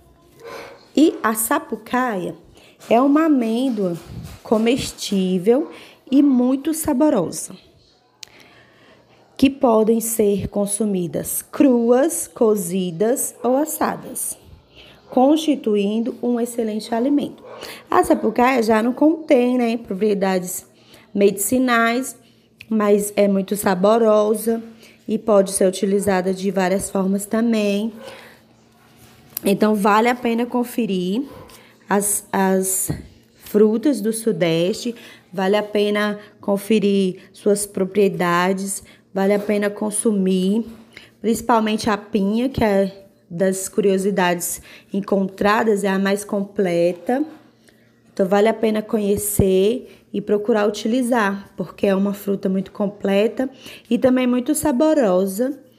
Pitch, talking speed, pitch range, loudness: 215 Hz, 100 wpm, 195-245 Hz, -19 LUFS